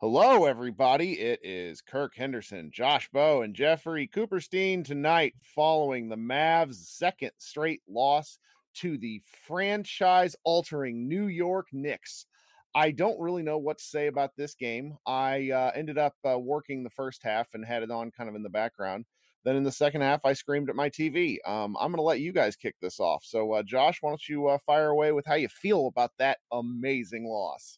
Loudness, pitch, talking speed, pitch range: -29 LUFS, 145 Hz, 190 wpm, 125-160 Hz